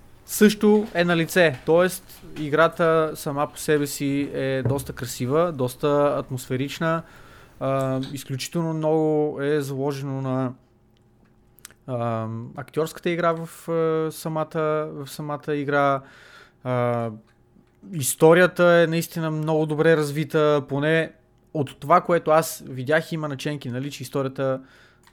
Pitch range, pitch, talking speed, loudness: 130-160 Hz, 150 Hz, 110 wpm, -23 LUFS